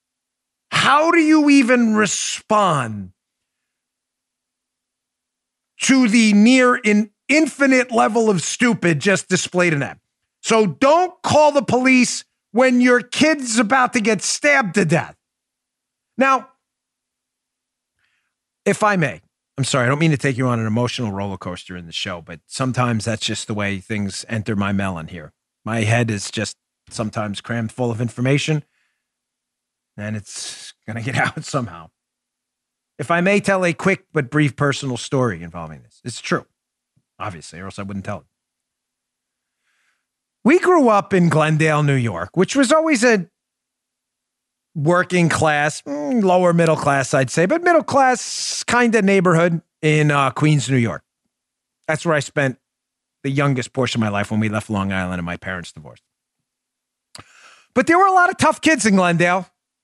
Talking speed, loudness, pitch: 160 wpm, -17 LUFS, 155 Hz